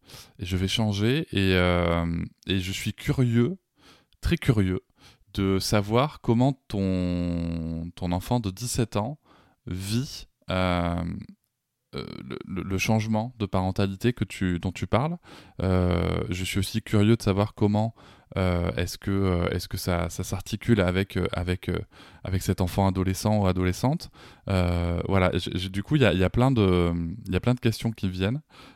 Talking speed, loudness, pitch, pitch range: 150 wpm, -26 LUFS, 95 Hz, 90-115 Hz